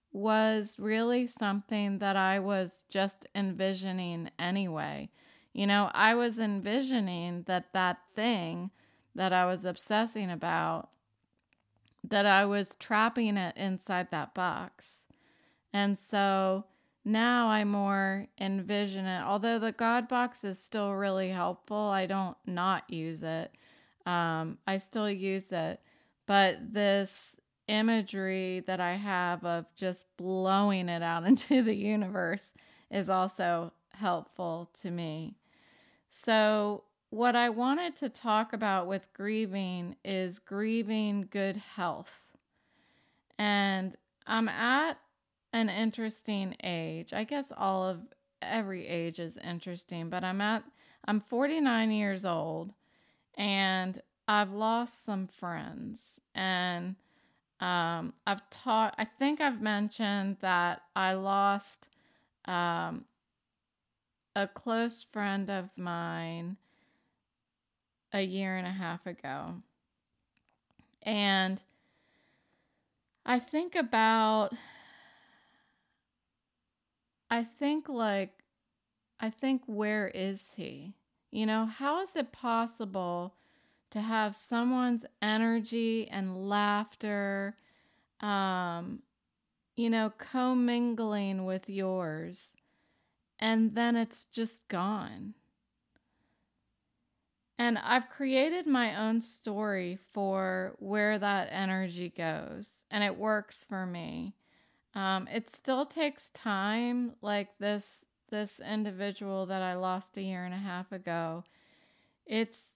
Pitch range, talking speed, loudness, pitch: 185-225 Hz, 110 wpm, -32 LUFS, 200 Hz